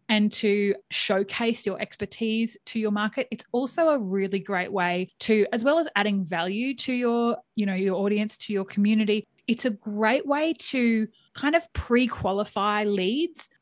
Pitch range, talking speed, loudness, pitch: 200-245 Hz, 165 wpm, -25 LUFS, 215 Hz